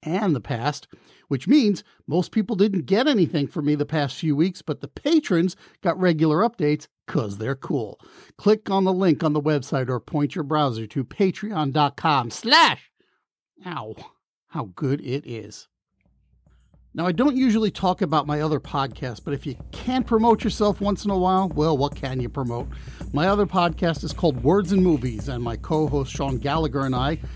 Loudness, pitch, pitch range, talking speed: -23 LUFS, 155 Hz, 140-190 Hz, 180 wpm